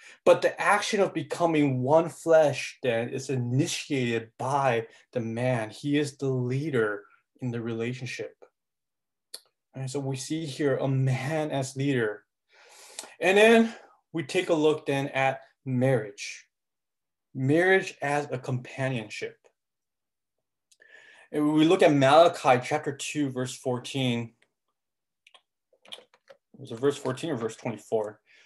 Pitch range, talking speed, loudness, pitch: 130-165 Hz, 120 wpm, -26 LUFS, 140 Hz